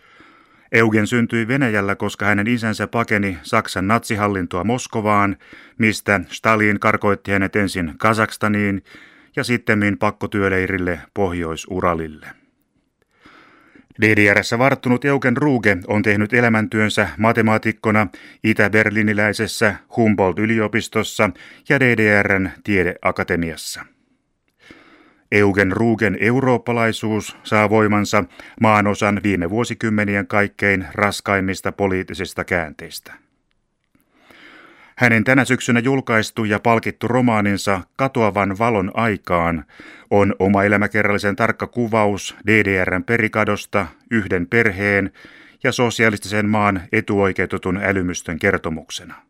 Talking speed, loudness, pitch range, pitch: 85 wpm, -18 LUFS, 100-115 Hz, 105 Hz